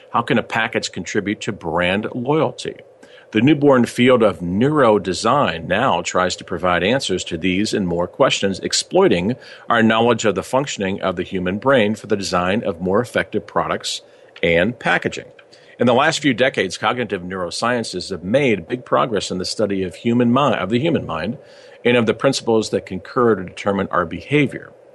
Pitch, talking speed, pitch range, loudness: 110 Hz, 175 wpm, 95-140 Hz, -18 LUFS